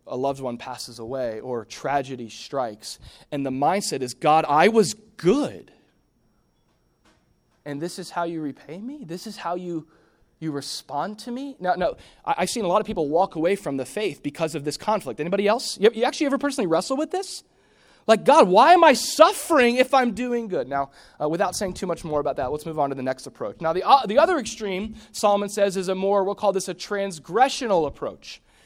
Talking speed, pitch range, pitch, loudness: 215 wpm, 145-230 Hz, 190 Hz, -22 LUFS